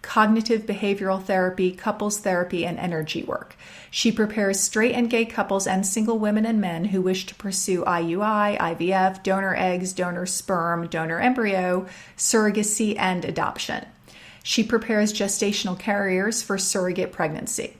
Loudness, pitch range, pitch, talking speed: -23 LUFS, 185-215 Hz, 195 Hz, 140 wpm